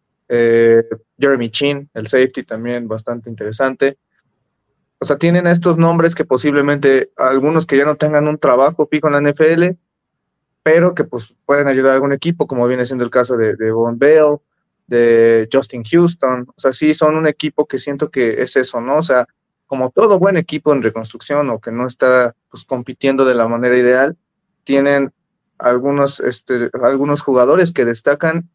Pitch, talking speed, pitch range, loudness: 140 Hz, 175 wpm, 125-155 Hz, -14 LUFS